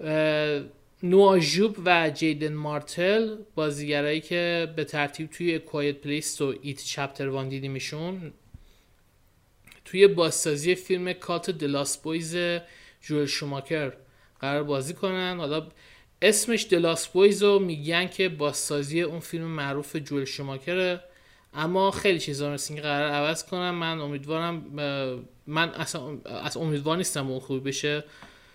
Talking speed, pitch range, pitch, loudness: 120 wpm, 145-175 Hz, 155 Hz, -26 LUFS